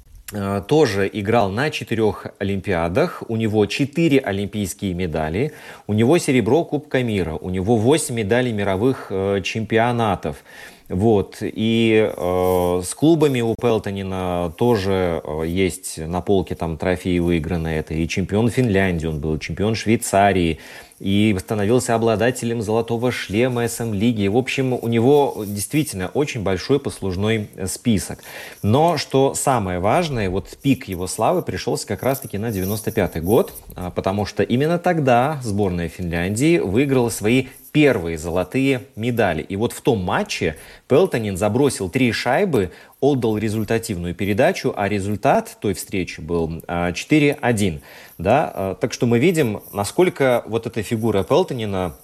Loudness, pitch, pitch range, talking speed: -20 LUFS, 110 Hz, 95-125 Hz, 130 wpm